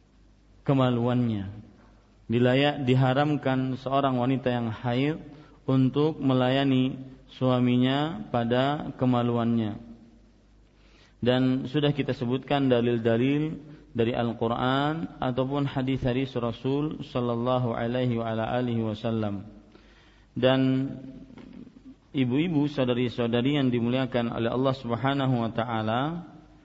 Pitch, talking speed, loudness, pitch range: 125 Hz, 80 wpm, -26 LUFS, 115-135 Hz